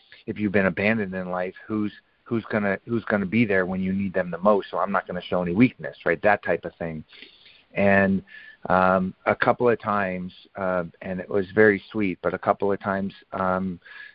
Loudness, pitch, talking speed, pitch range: -24 LUFS, 95 Hz, 210 wpm, 95-105 Hz